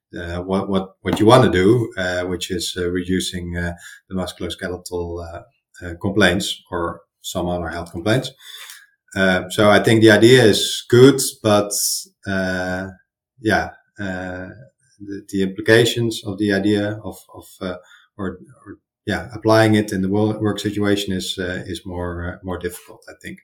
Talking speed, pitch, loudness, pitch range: 160 wpm, 95 Hz, -18 LUFS, 90-105 Hz